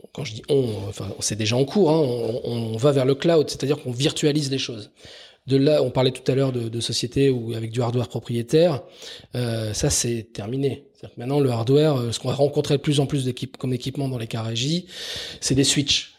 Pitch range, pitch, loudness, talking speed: 115-145 Hz, 130 Hz, -22 LUFS, 225 wpm